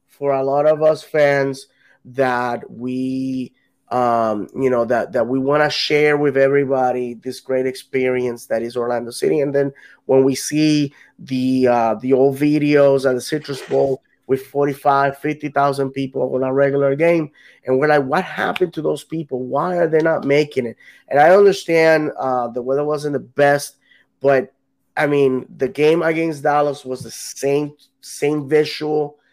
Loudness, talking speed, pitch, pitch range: -18 LUFS, 170 wpm, 140 Hz, 130-150 Hz